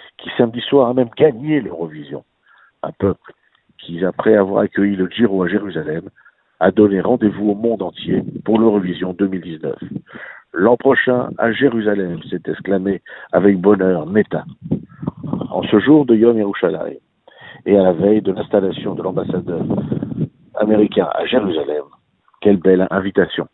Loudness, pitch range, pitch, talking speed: -17 LUFS, 95-115 Hz, 105 Hz, 140 wpm